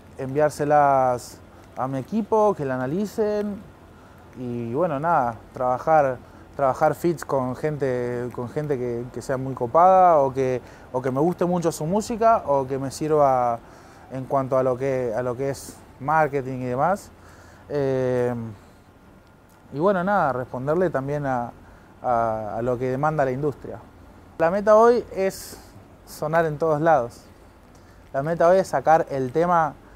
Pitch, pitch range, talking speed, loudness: 130 Hz, 120-155 Hz, 150 wpm, -22 LUFS